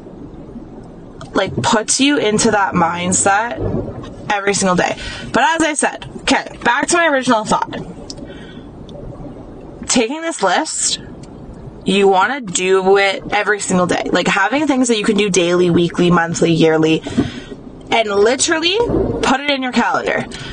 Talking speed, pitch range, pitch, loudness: 135 wpm, 185-265 Hz, 205 Hz, -15 LUFS